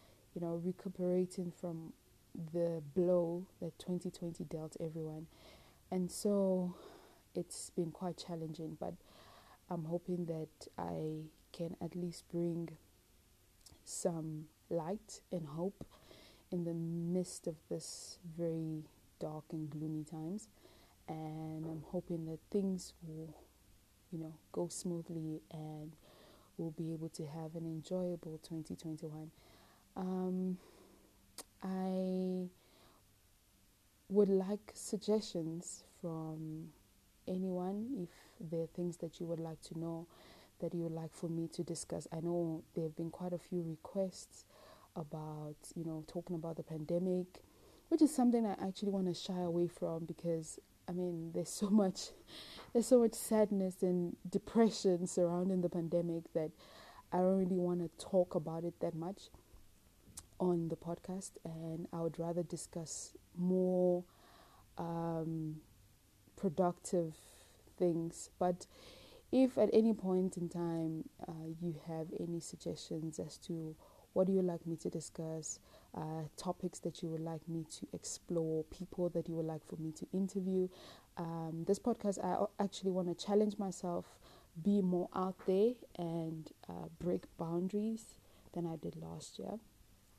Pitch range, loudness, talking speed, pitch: 160-185 Hz, -39 LUFS, 135 wpm, 170 Hz